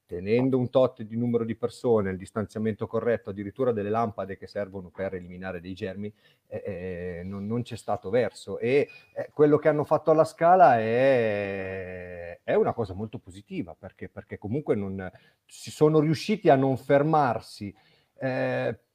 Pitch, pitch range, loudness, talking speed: 110 Hz, 95-125 Hz, -26 LUFS, 160 wpm